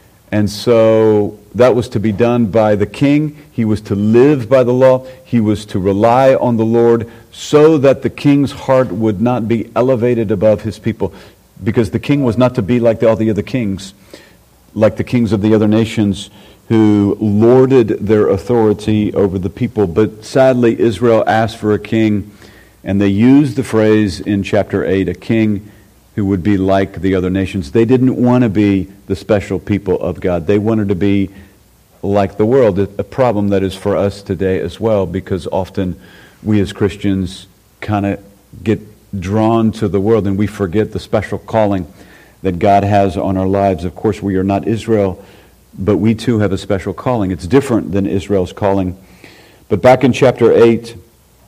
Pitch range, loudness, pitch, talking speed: 100-115 Hz, -14 LUFS, 105 Hz, 185 wpm